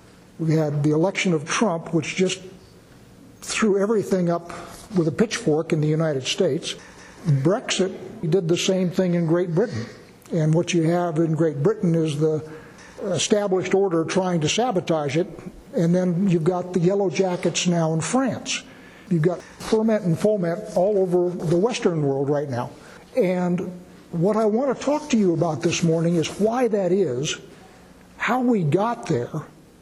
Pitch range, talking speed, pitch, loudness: 165-195 Hz, 165 wpm, 180 Hz, -22 LUFS